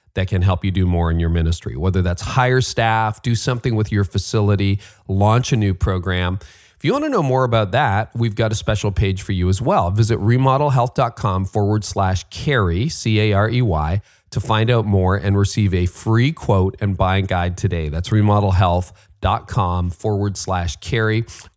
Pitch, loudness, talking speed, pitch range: 100 Hz, -19 LUFS, 175 wpm, 95-115 Hz